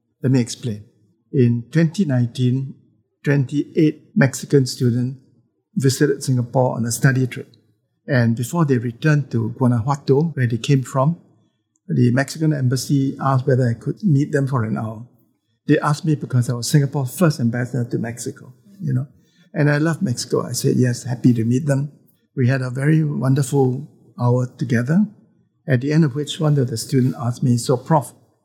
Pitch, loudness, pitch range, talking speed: 130 Hz, -19 LUFS, 120-145 Hz, 170 wpm